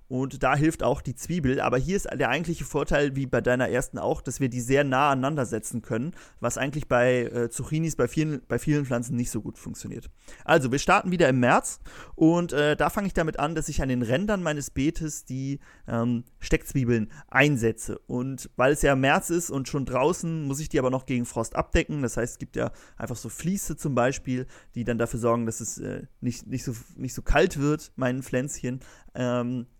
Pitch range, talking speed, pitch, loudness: 120-150 Hz, 215 wpm, 130 Hz, -26 LUFS